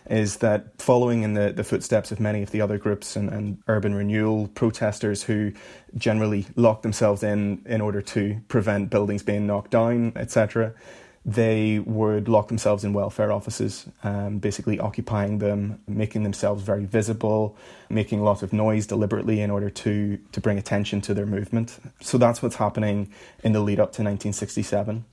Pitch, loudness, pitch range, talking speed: 105 Hz, -24 LUFS, 100-110 Hz, 175 wpm